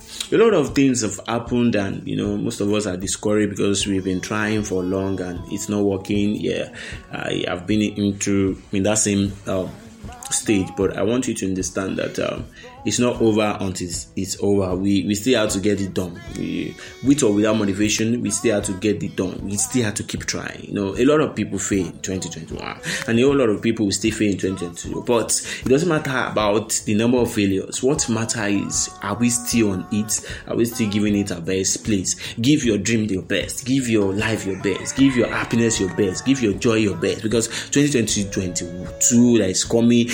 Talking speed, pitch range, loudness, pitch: 215 wpm, 95-115 Hz, -21 LUFS, 105 Hz